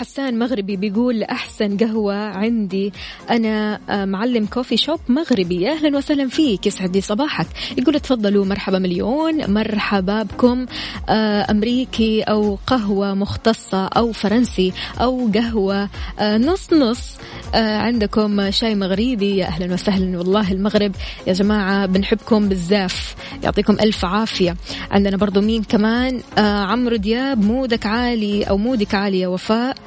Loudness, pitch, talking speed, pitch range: -18 LUFS, 210 Hz, 120 wpm, 200-235 Hz